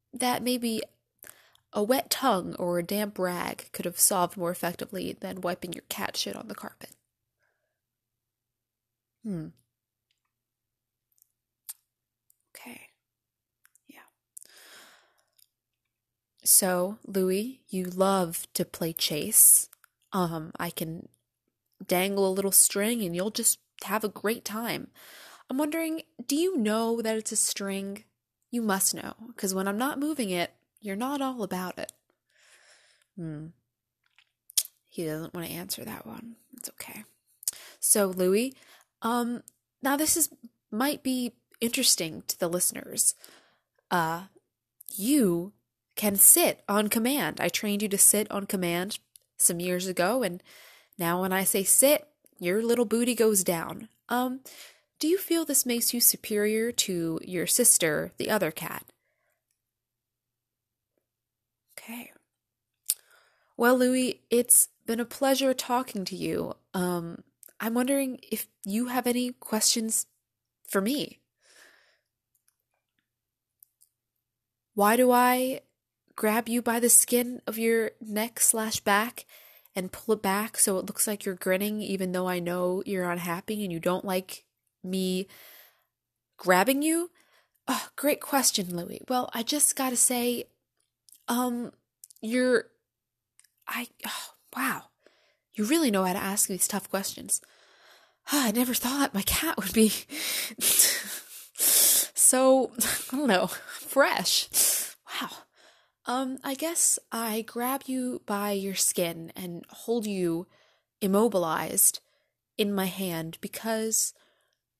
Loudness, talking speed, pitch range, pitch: -26 LUFS, 125 wpm, 175-240 Hz, 205 Hz